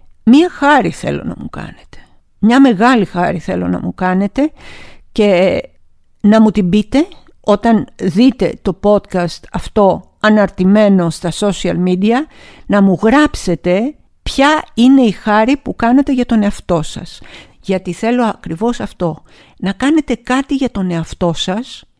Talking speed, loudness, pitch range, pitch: 140 wpm, -13 LUFS, 185-245 Hz, 210 Hz